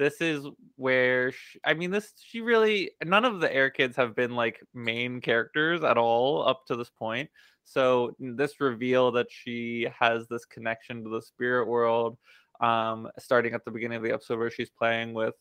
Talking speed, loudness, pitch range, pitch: 190 wpm, -27 LUFS, 115-135 Hz, 120 Hz